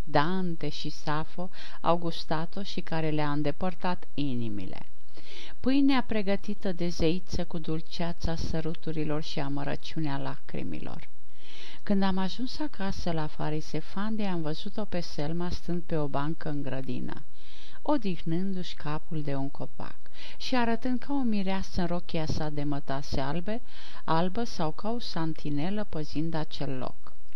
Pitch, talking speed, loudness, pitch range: 165 Hz, 130 wpm, -32 LUFS, 150-195 Hz